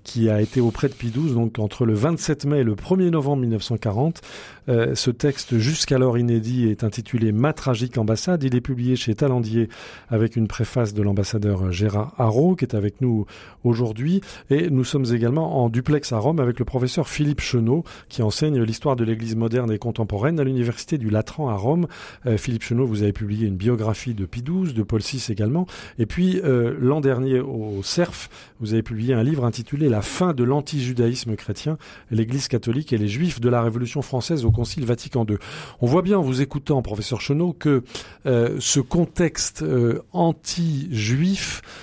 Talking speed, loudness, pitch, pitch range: 185 wpm, -22 LUFS, 125 Hz, 115-145 Hz